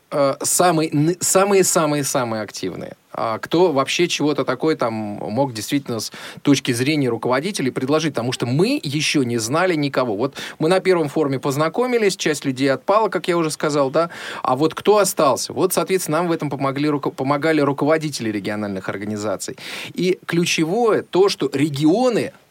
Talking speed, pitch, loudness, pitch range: 150 wpm, 150 Hz, -19 LUFS, 135-170 Hz